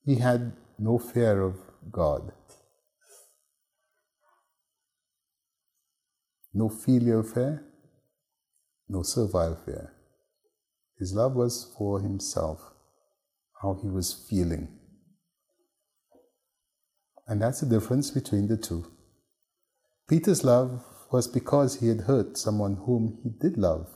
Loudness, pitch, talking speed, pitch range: -27 LUFS, 120 Hz, 100 wpm, 100-130 Hz